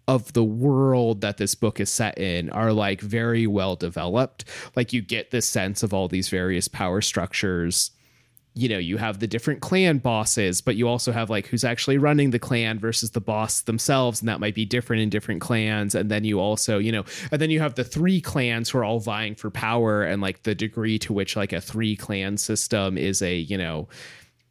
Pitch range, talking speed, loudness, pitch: 100-120 Hz, 220 wpm, -24 LUFS, 110 Hz